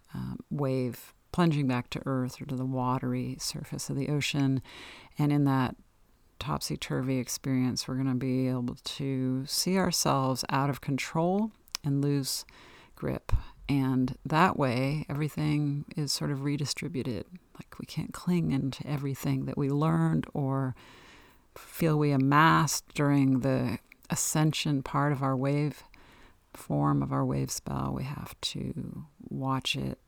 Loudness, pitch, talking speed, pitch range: -30 LUFS, 135 Hz, 140 wpm, 130-150 Hz